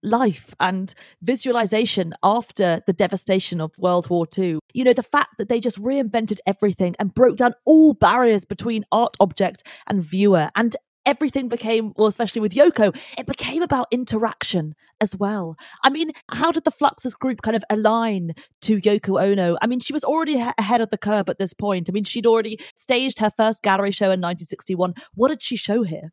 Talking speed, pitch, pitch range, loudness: 195 wpm, 215 Hz, 190-245 Hz, -20 LUFS